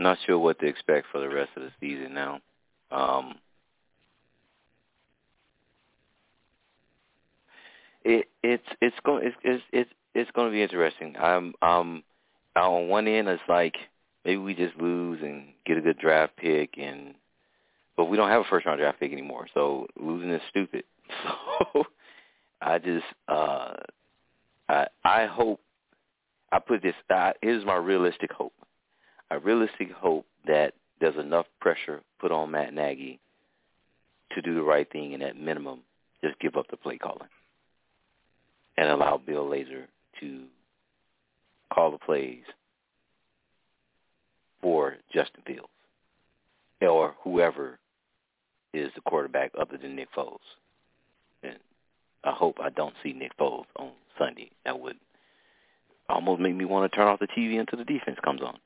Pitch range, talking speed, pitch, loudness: 70-95 Hz, 145 wpm, 80 Hz, -27 LUFS